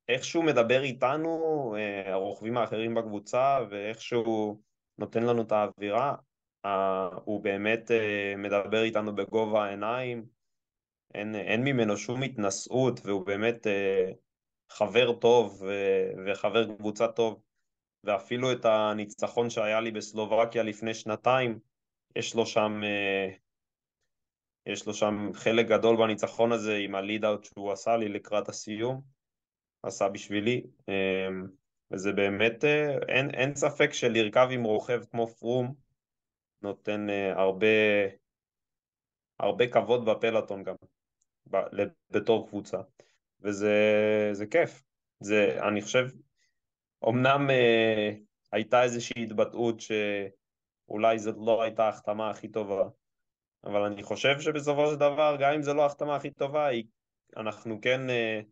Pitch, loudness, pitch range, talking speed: 110 Hz, -28 LUFS, 105-125 Hz, 110 wpm